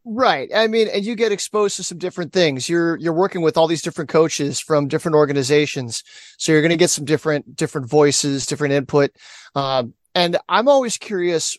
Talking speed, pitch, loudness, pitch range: 195 wpm, 160 Hz, -18 LUFS, 145-180 Hz